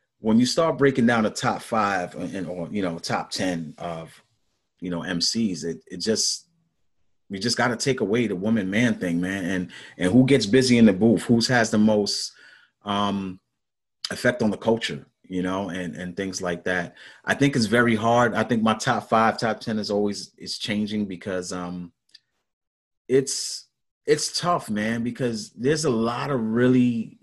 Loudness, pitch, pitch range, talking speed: -23 LUFS, 110 Hz, 95-120 Hz, 185 wpm